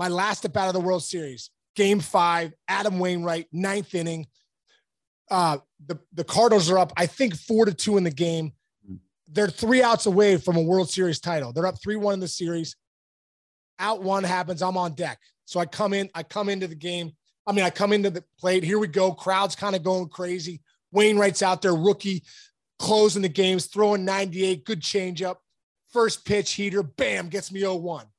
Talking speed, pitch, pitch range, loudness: 195 wpm, 185 Hz, 170-200 Hz, -24 LUFS